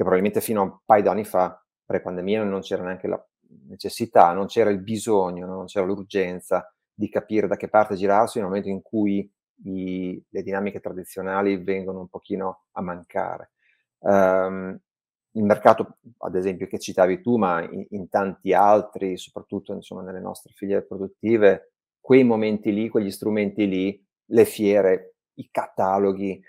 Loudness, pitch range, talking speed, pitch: -23 LUFS, 95-105 Hz, 165 wpm, 100 Hz